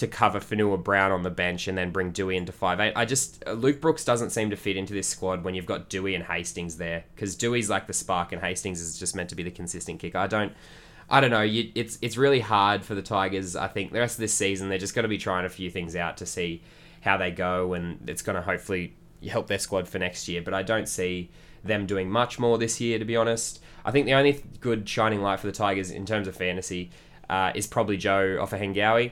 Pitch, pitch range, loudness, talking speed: 100 Hz, 90-115 Hz, -27 LUFS, 260 wpm